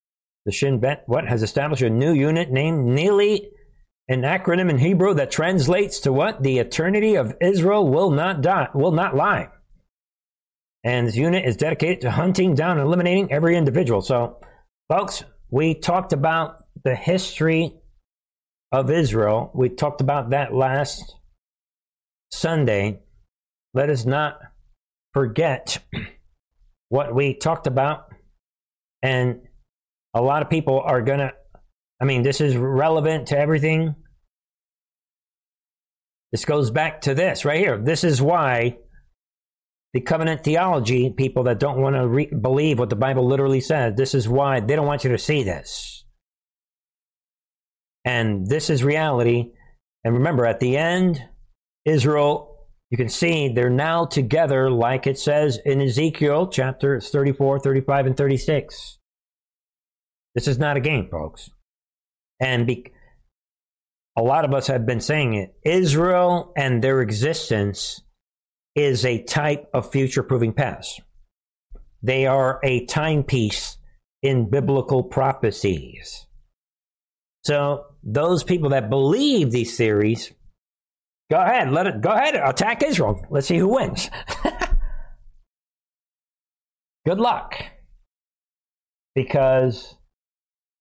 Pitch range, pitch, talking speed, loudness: 120-150 Hz, 135 Hz, 130 wpm, -21 LUFS